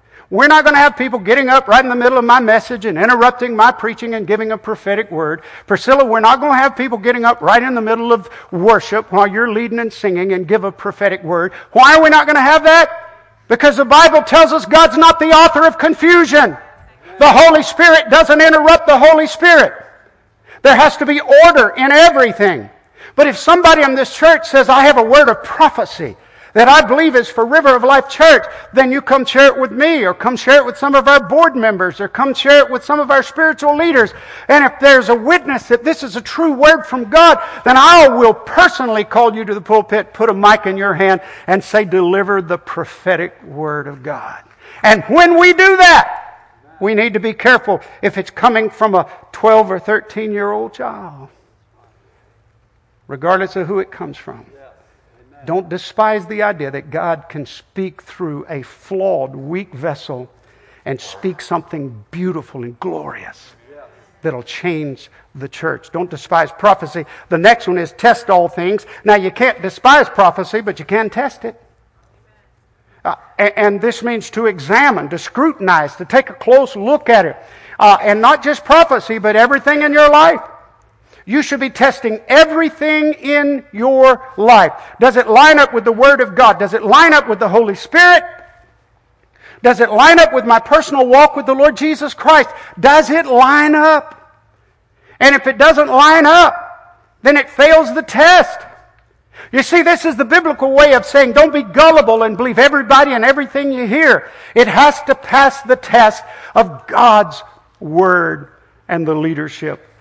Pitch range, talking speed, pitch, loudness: 200-295 Hz, 190 wpm, 250 Hz, -10 LUFS